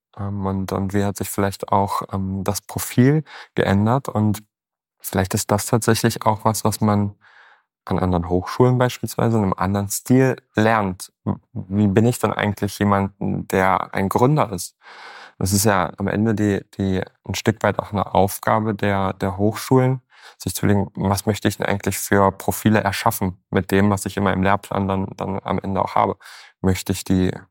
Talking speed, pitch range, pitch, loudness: 180 wpm, 95-110 Hz, 100 Hz, -20 LUFS